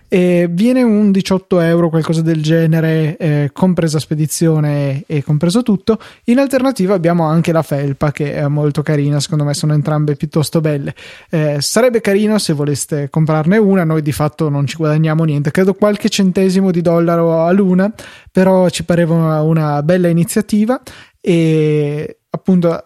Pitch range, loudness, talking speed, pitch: 150-190 Hz, -14 LUFS, 155 wpm, 165 Hz